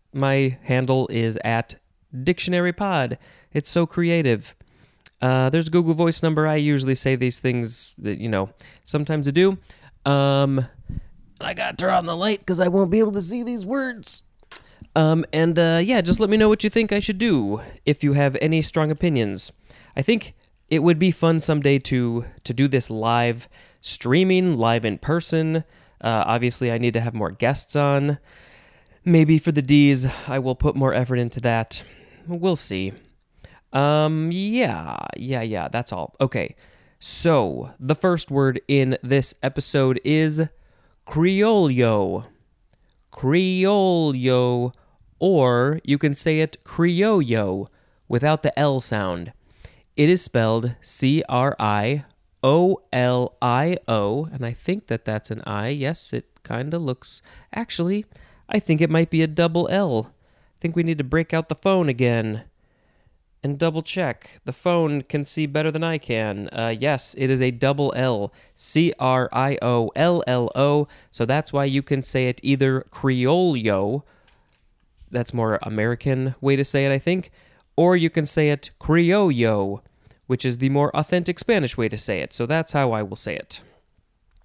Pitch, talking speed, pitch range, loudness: 140 Hz, 165 wpm, 120-165 Hz, -21 LUFS